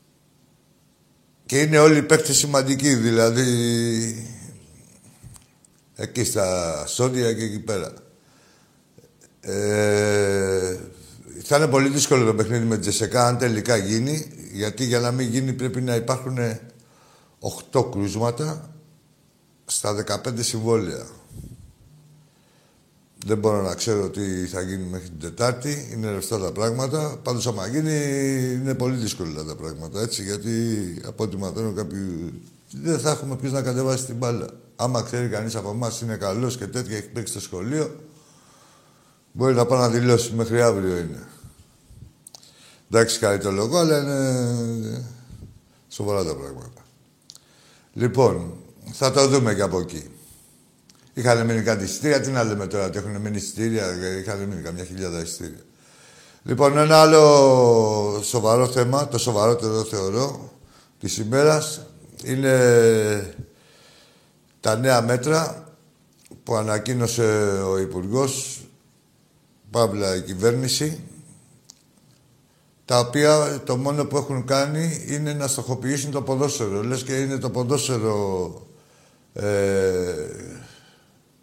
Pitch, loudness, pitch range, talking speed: 120 Hz, -22 LUFS, 105-135 Hz, 125 wpm